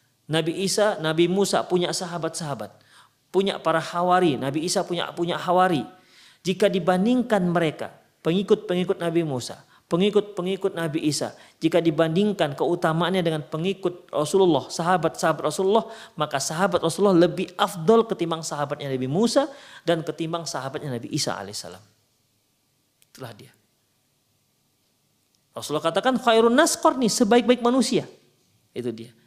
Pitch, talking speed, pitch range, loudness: 170 Hz, 115 wpm, 145-195 Hz, -23 LUFS